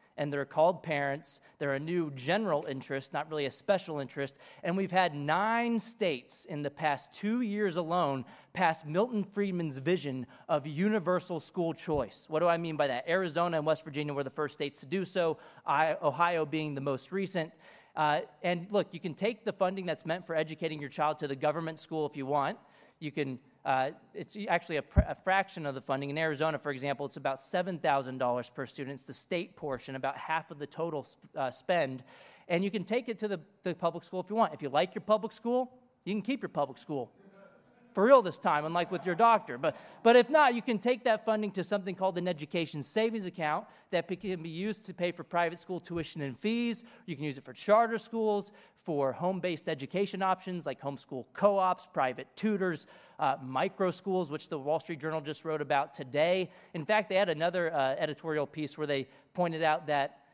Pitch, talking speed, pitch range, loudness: 165 Hz, 210 wpm, 145-190 Hz, -32 LUFS